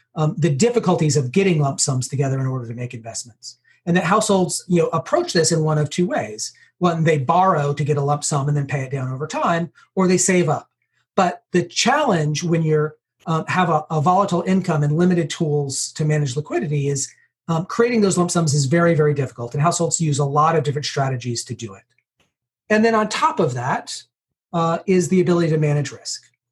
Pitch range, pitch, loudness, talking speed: 140-175 Hz, 155 Hz, -19 LUFS, 215 wpm